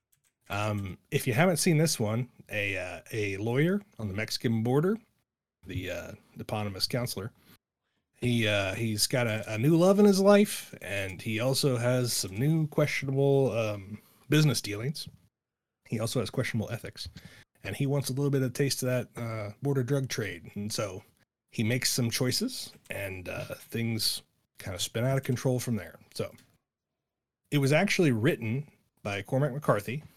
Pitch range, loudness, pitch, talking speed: 105-140 Hz, -29 LUFS, 120 Hz, 170 wpm